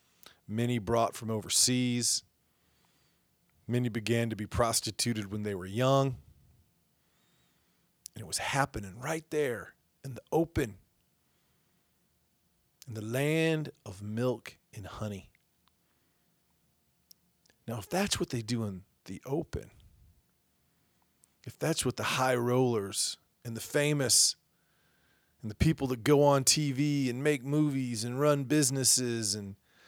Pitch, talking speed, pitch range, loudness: 120 Hz, 125 wpm, 110-135 Hz, -30 LUFS